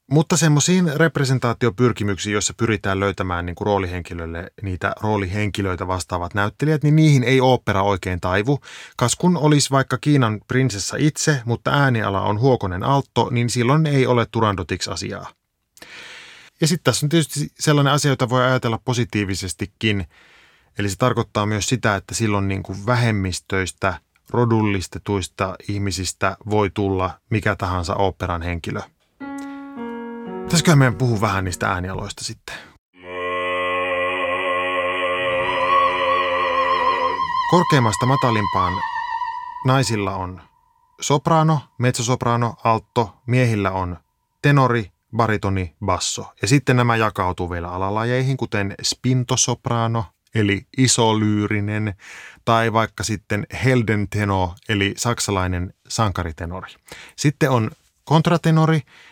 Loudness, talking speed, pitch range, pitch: -20 LUFS, 105 wpm, 95-130 Hz, 110 Hz